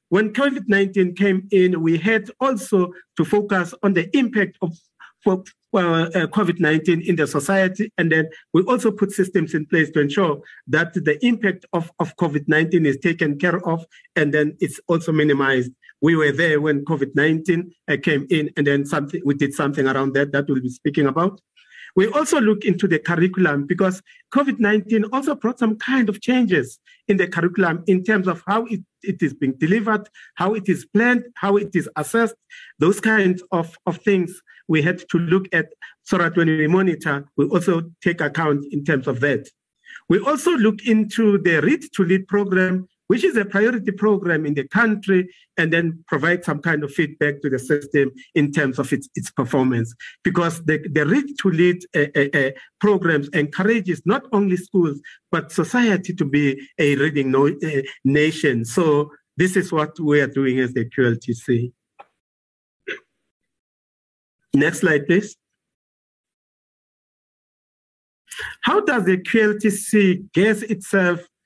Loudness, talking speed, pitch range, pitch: -20 LUFS, 165 wpm, 150-200 Hz, 175 Hz